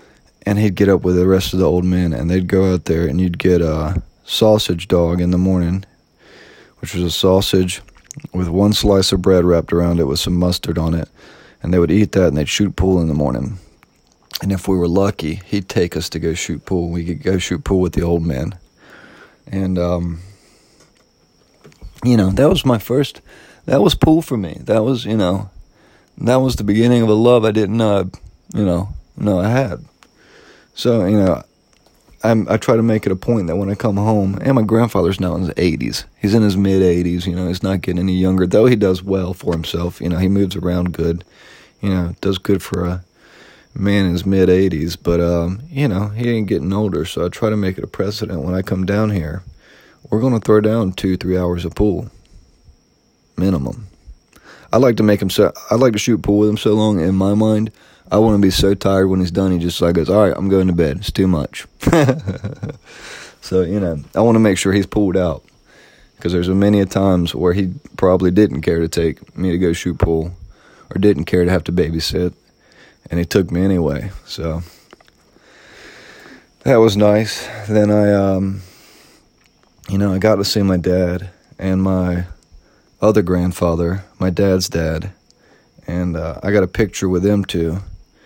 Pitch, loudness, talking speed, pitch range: 95 Hz, -16 LUFS, 210 wpm, 85-105 Hz